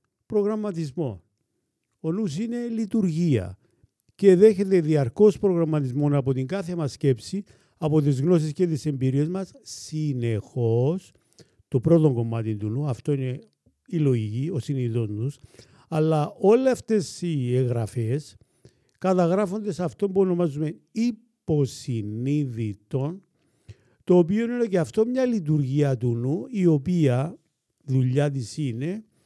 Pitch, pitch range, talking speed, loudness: 150 Hz, 125-180 Hz, 120 wpm, -24 LUFS